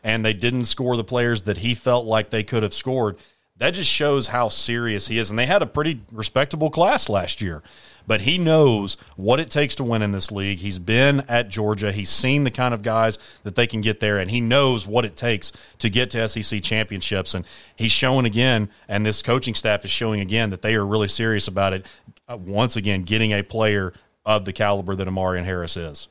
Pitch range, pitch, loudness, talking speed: 100-120 Hz, 110 Hz, -21 LUFS, 225 wpm